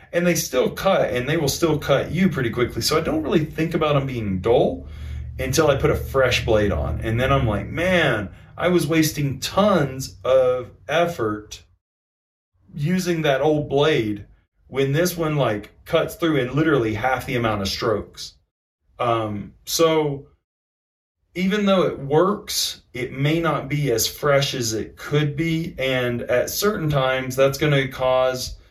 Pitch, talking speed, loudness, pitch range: 130 Hz, 165 wpm, -21 LUFS, 105-155 Hz